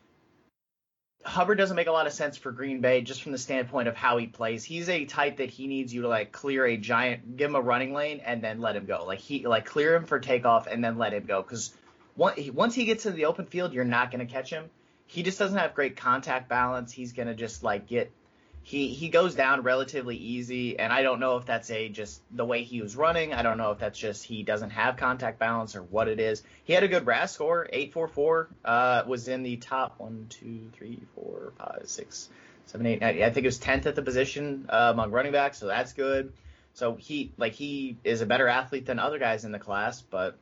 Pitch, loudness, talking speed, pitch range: 125 Hz, -28 LUFS, 240 wpm, 115-145 Hz